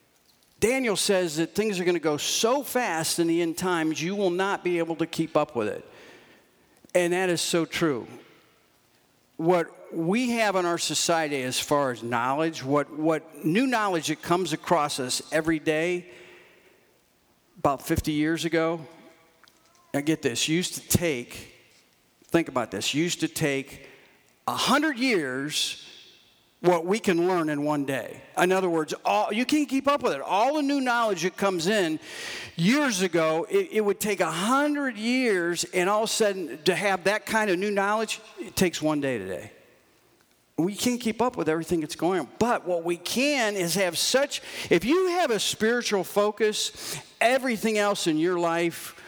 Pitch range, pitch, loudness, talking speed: 160-215 Hz, 175 Hz, -25 LUFS, 175 wpm